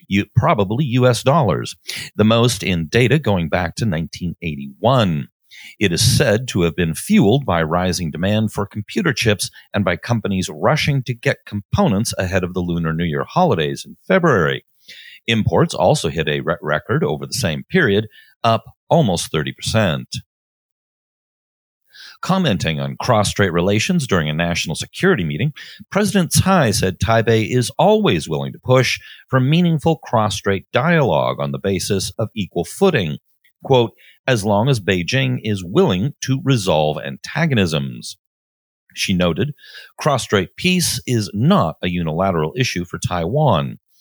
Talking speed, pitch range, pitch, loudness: 140 wpm, 90-130 Hz, 105 Hz, -18 LUFS